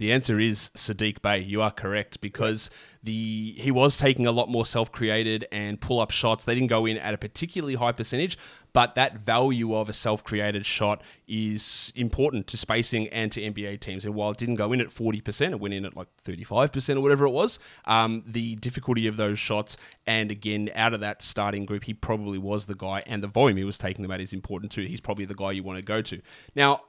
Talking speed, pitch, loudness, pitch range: 225 wpm, 110 Hz, -26 LUFS, 105-120 Hz